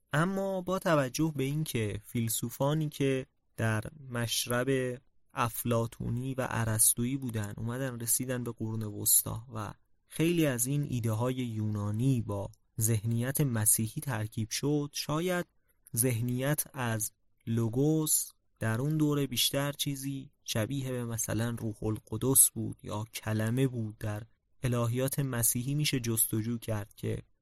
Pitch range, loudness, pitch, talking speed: 110-135 Hz, -31 LUFS, 120 Hz, 120 wpm